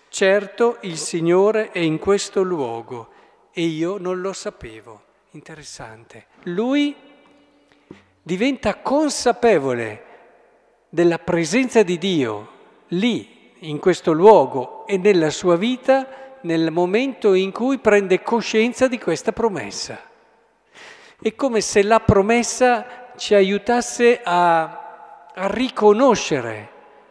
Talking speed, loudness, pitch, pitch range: 105 wpm, -19 LUFS, 205 Hz, 175-240 Hz